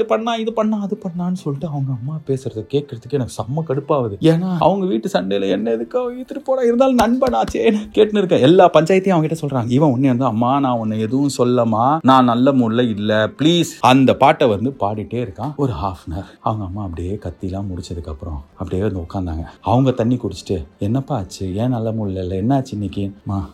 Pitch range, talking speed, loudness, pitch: 100-160 Hz, 185 wpm, -18 LUFS, 125 Hz